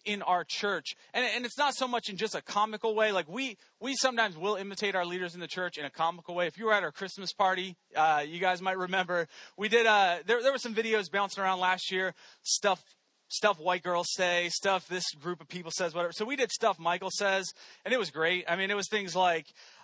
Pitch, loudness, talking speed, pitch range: 190 Hz, -30 LUFS, 240 wpm, 175-215 Hz